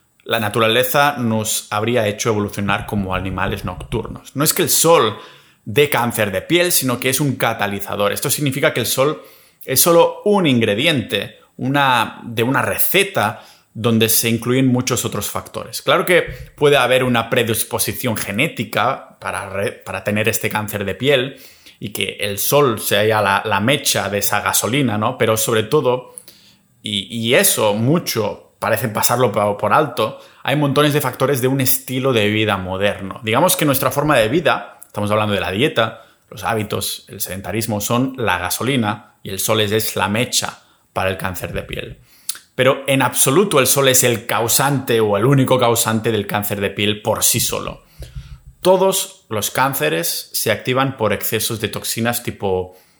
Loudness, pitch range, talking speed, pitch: -17 LUFS, 105-130 Hz, 170 wpm, 115 Hz